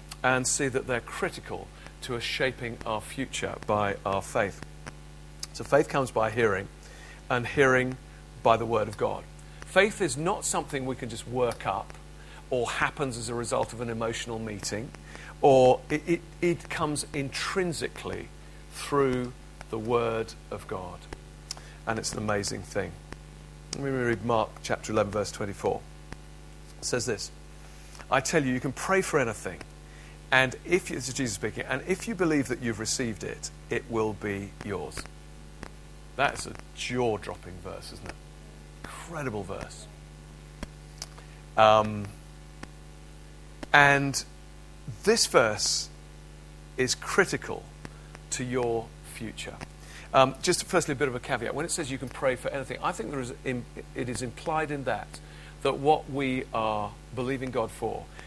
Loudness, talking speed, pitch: -28 LUFS, 150 wpm, 105 Hz